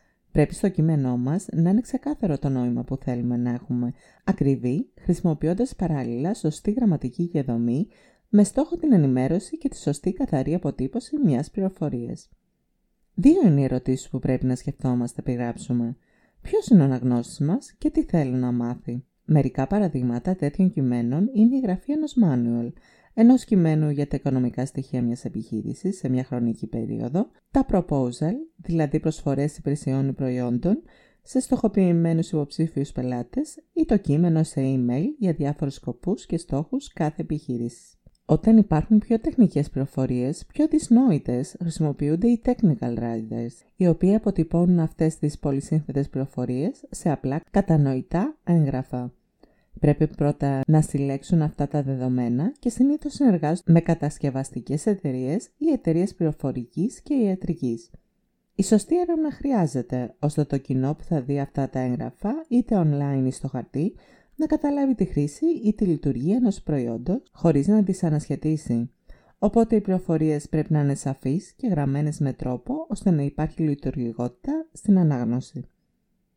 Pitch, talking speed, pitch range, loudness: 155 Hz, 140 wpm, 135-205 Hz, -24 LUFS